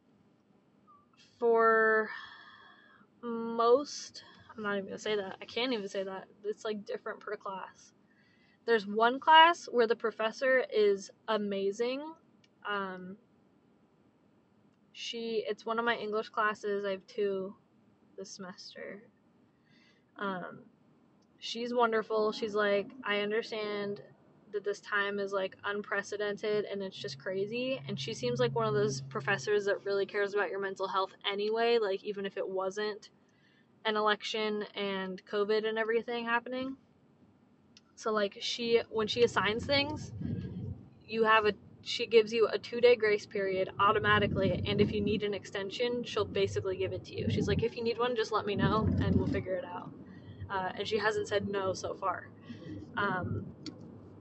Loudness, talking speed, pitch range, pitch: -32 LUFS, 155 wpm, 200-230 Hz, 210 Hz